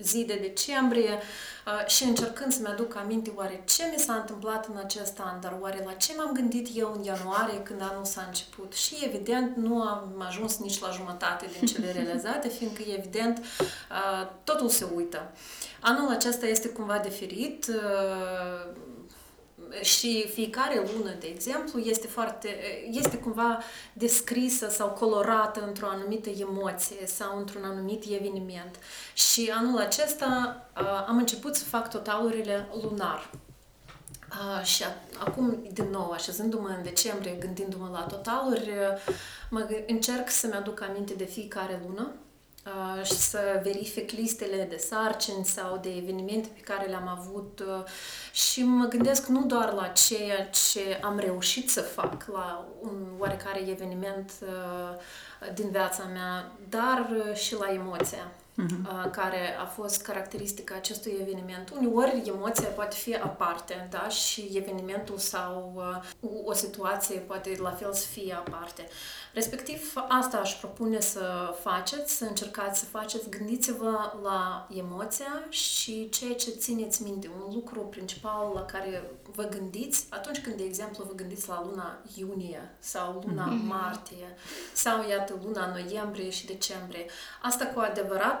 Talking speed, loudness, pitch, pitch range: 140 wpm, -30 LUFS, 205 Hz, 190-225 Hz